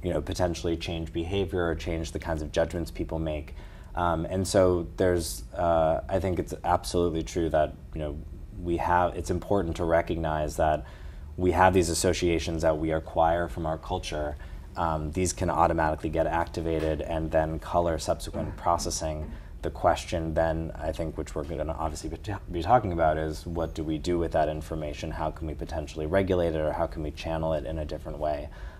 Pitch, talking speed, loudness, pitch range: 80 Hz, 190 wpm, -28 LUFS, 80-85 Hz